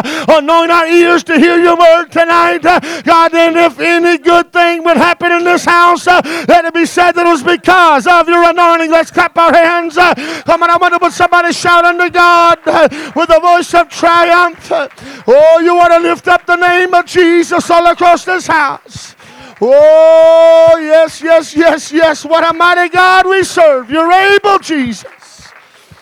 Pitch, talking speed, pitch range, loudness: 340 Hz, 180 wpm, 330-350 Hz, -8 LUFS